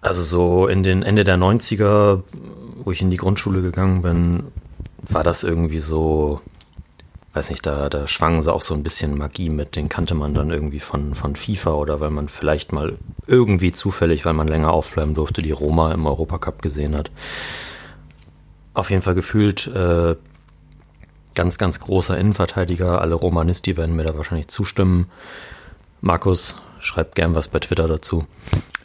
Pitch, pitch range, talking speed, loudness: 85 Hz, 80-95 Hz, 165 wpm, -19 LUFS